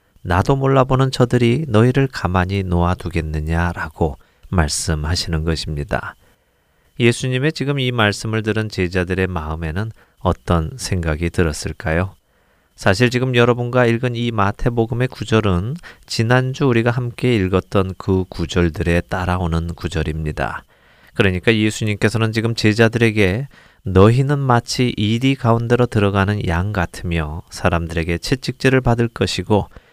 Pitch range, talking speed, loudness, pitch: 85-120 Hz, 315 characters per minute, -18 LUFS, 100 Hz